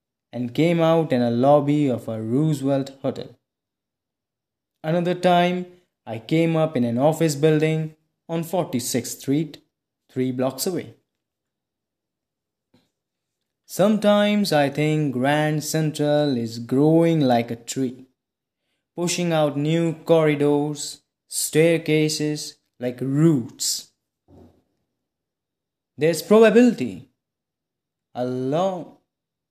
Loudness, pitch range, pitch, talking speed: -21 LUFS, 130-165 Hz, 150 Hz, 95 wpm